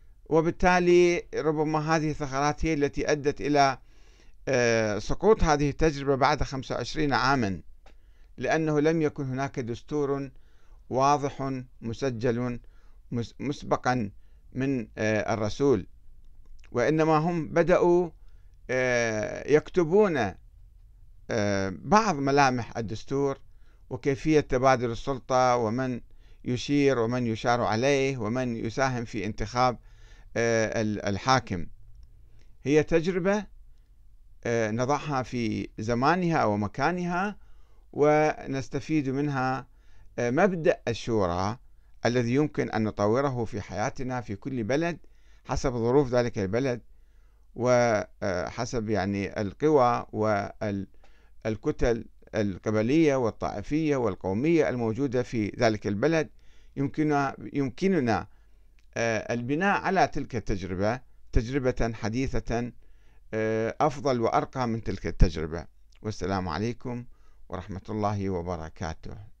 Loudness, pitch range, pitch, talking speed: -27 LUFS, 105-140 Hz, 120 Hz, 85 wpm